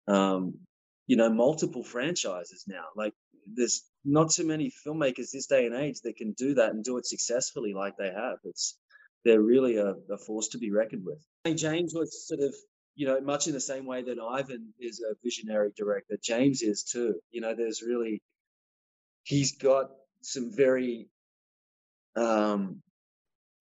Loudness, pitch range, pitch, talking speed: -29 LUFS, 110-140 Hz, 120 Hz, 175 wpm